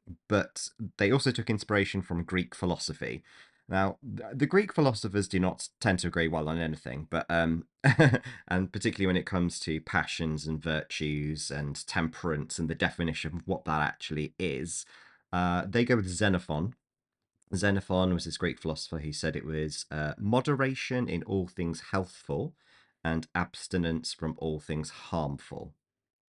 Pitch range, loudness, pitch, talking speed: 80-100 Hz, -31 LUFS, 90 Hz, 155 wpm